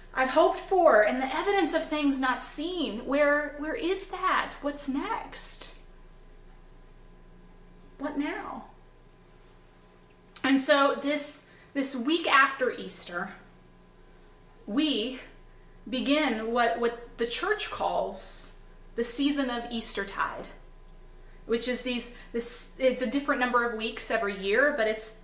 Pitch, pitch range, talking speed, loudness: 250 Hz, 205-290 Hz, 120 wpm, -27 LUFS